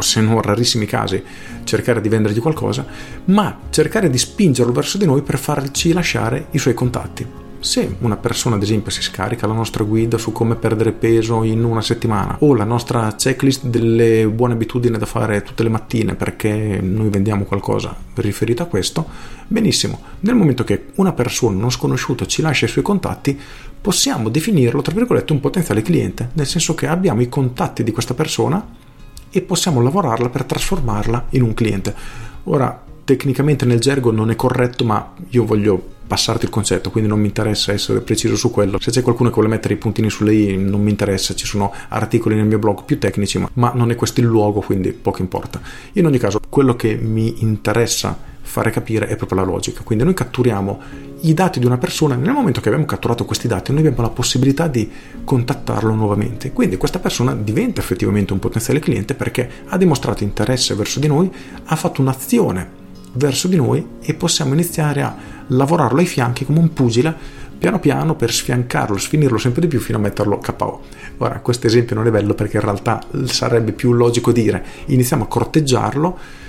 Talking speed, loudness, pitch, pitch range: 185 wpm, -17 LUFS, 120 Hz, 110-140 Hz